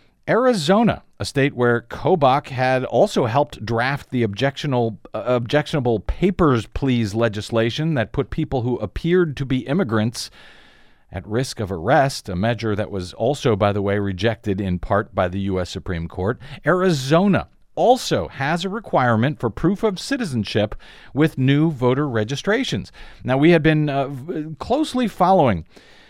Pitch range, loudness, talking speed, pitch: 110-155 Hz, -20 LUFS, 145 wpm, 130 Hz